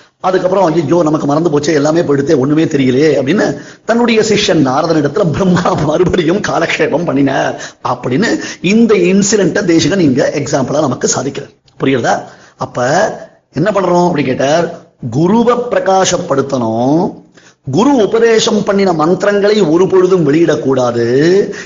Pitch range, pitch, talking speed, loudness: 150-200 Hz, 175 Hz, 115 wpm, -11 LUFS